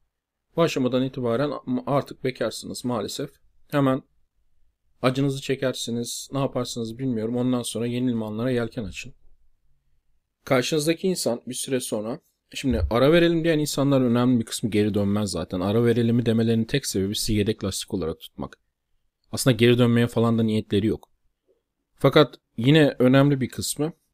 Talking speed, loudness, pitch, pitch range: 140 wpm, -23 LUFS, 120 Hz, 110-135 Hz